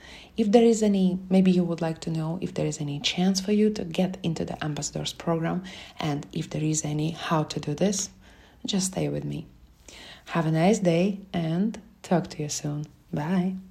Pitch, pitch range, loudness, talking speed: 170 Hz, 155-190 Hz, -26 LUFS, 200 wpm